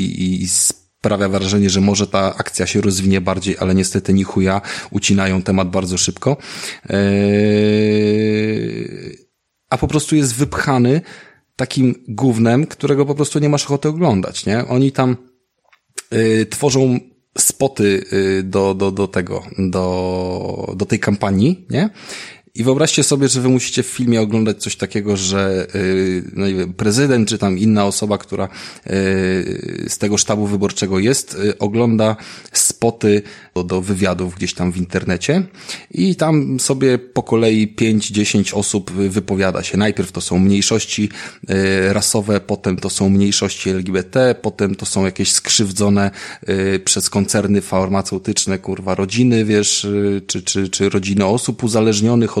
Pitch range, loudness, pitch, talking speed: 95-120 Hz, -16 LUFS, 100 Hz, 135 wpm